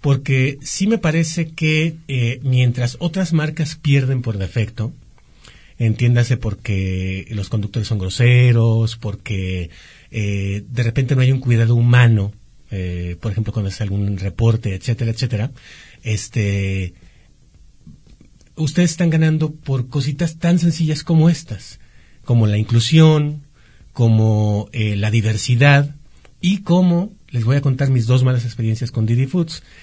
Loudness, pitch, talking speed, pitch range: -18 LUFS, 120 Hz, 135 wpm, 110-145 Hz